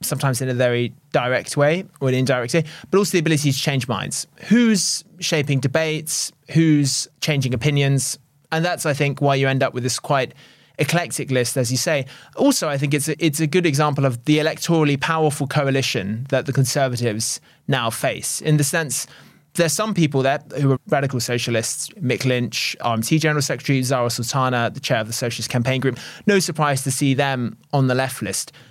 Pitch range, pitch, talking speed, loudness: 130-160 Hz, 140 Hz, 190 wpm, -20 LUFS